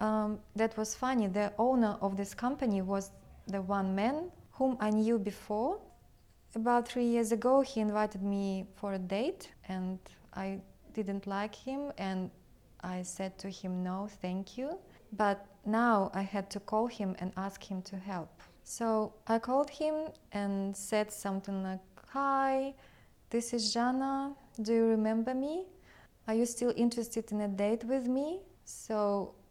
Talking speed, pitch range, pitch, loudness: 160 wpm, 195-240 Hz, 215 Hz, -34 LUFS